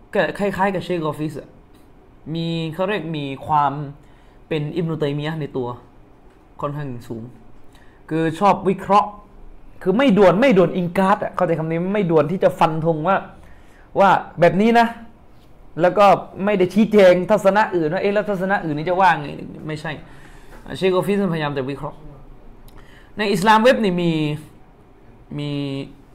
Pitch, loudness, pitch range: 165 Hz, -19 LUFS, 145-195 Hz